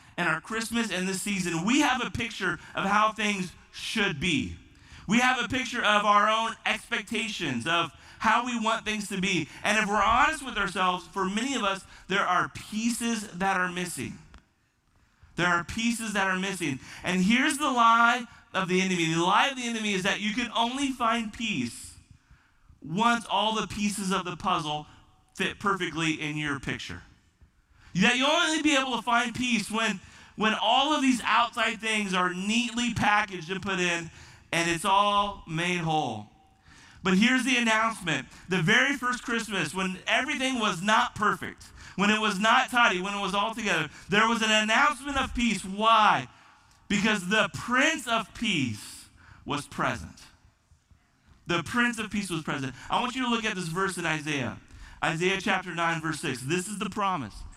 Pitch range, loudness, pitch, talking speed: 170-230 Hz, -26 LUFS, 200 Hz, 180 wpm